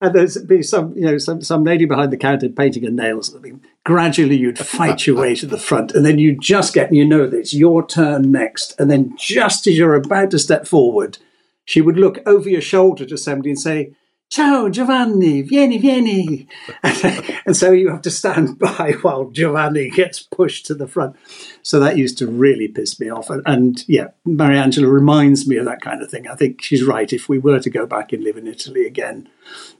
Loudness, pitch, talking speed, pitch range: -15 LUFS, 155 Hz, 215 wpm, 140-185 Hz